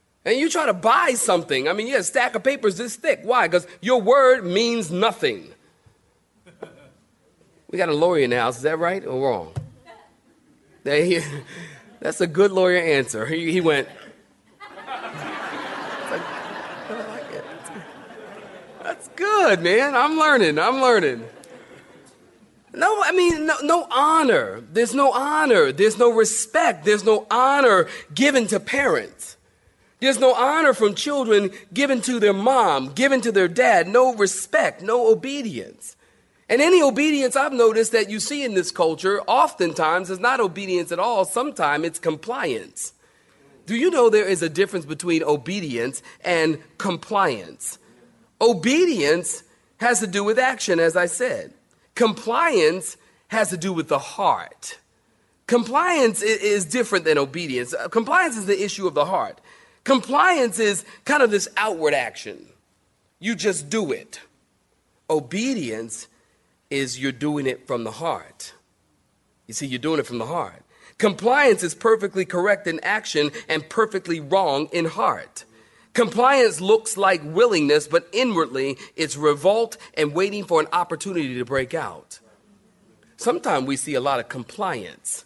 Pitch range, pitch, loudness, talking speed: 170-255 Hz, 210 Hz, -20 LUFS, 145 wpm